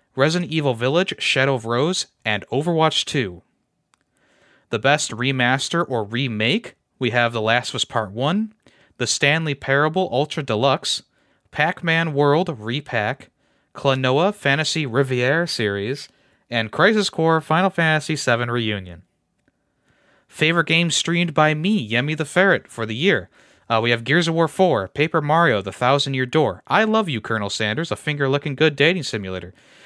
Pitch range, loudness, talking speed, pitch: 120-165 Hz, -20 LUFS, 155 wpm, 140 Hz